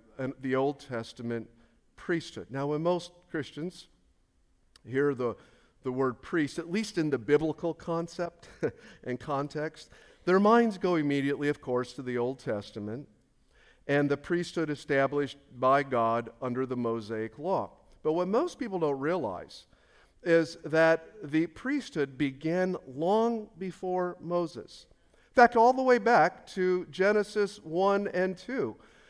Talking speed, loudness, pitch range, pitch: 140 wpm, -30 LUFS, 130-180 Hz, 155 Hz